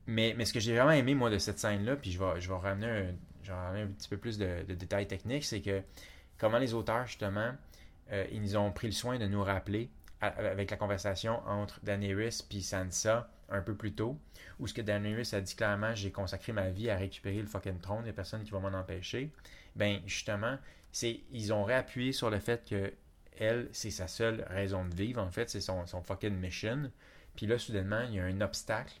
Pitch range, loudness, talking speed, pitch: 95-115 Hz, -35 LUFS, 225 wpm, 105 Hz